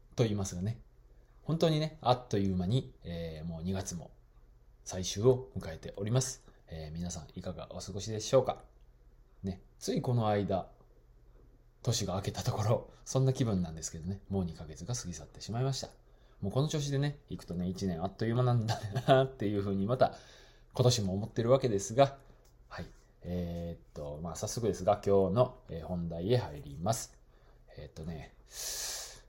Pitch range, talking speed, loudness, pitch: 90-125 Hz, 340 characters per minute, -33 LUFS, 105 Hz